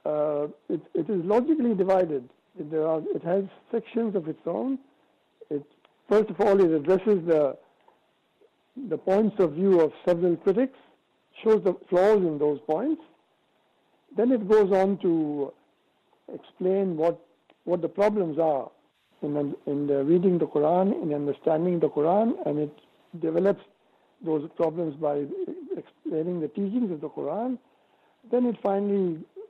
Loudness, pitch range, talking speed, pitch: -26 LUFS, 155-210 Hz, 140 wpm, 185 Hz